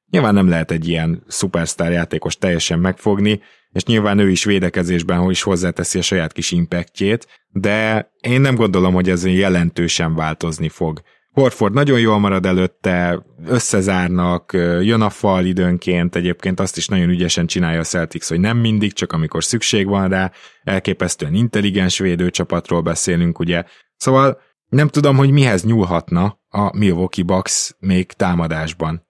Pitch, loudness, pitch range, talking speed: 90 Hz, -17 LUFS, 85-105 Hz, 150 wpm